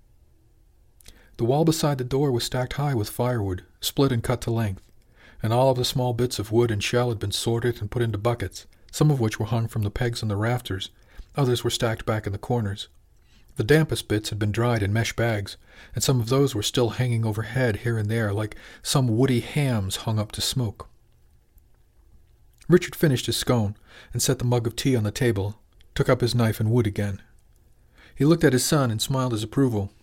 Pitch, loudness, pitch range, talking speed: 115 Hz, -24 LUFS, 105-125 Hz, 215 wpm